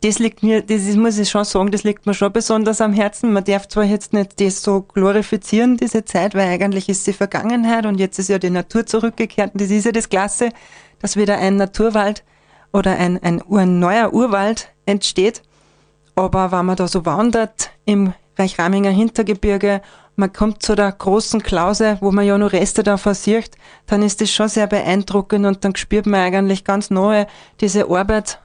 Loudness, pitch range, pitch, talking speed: -17 LUFS, 195-215 Hz, 205 Hz, 190 wpm